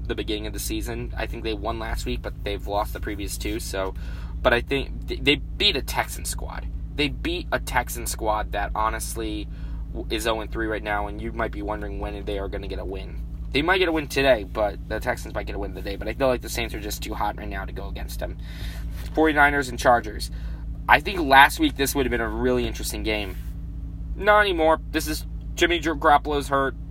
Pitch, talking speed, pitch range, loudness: 105 Hz, 225 wpm, 85-125 Hz, -24 LUFS